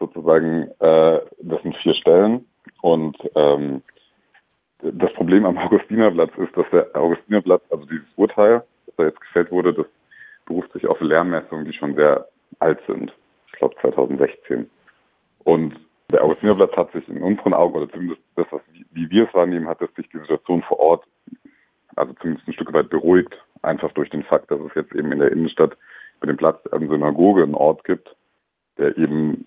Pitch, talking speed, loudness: 110 Hz, 180 wpm, -19 LUFS